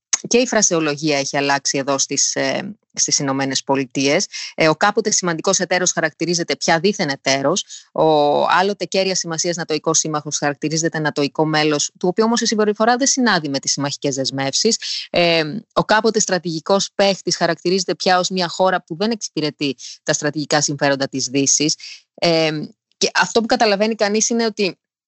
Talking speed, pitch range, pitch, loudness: 150 wpm, 145-200 Hz, 165 Hz, -18 LUFS